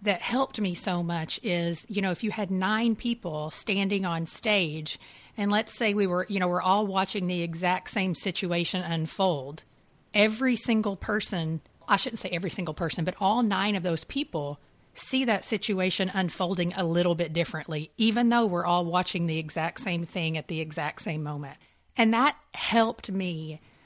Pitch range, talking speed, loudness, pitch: 165-210 Hz, 180 wpm, -28 LUFS, 185 Hz